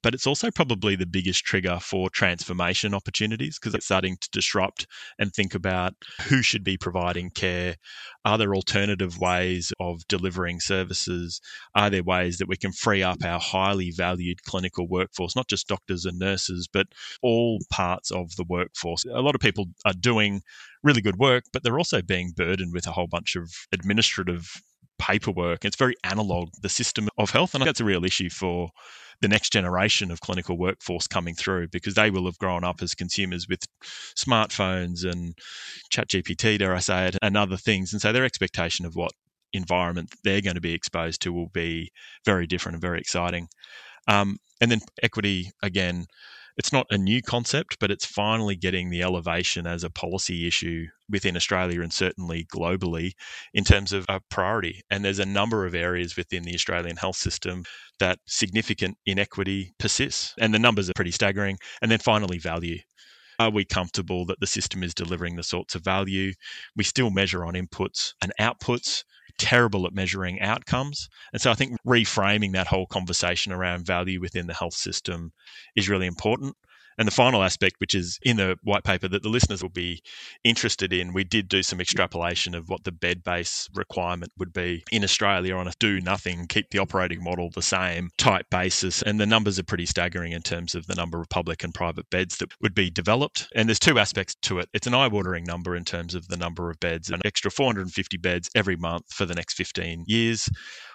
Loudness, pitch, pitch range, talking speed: -25 LUFS, 95 Hz, 90-105 Hz, 195 wpm